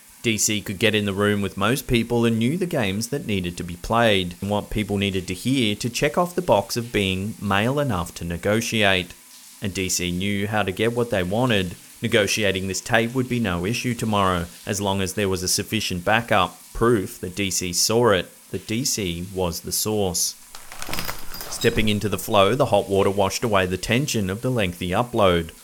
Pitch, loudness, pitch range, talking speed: 105 Hz, -22 LUFS, 95-115 Hz, 200 wpm